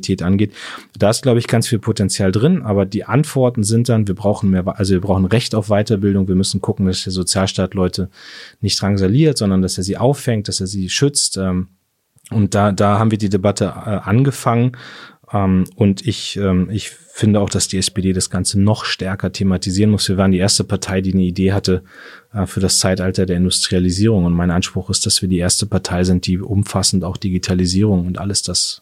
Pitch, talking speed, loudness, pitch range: 100 Hz, 195 wpm, -16 LUFS, 95-105 Hz